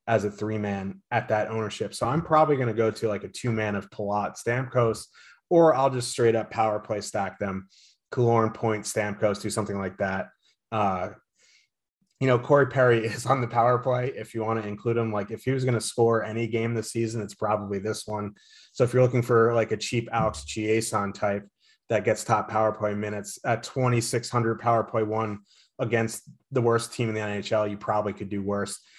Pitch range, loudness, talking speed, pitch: 105-120 Hz, -26 LUFS, 210 wpm, 110 Hz